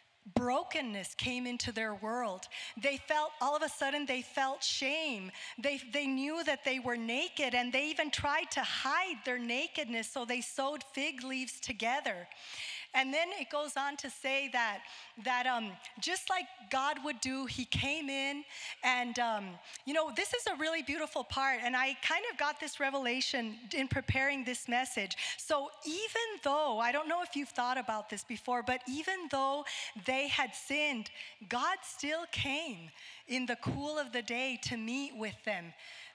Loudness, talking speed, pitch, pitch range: -35 LUFS, 175 wpm, 270 Hz, 245-295 Hz